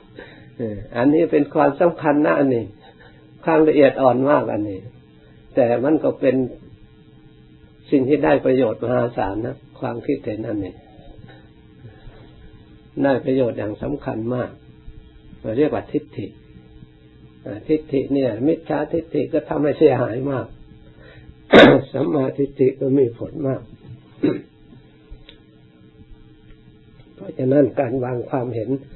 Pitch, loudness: 125 Hz, -19 LUFS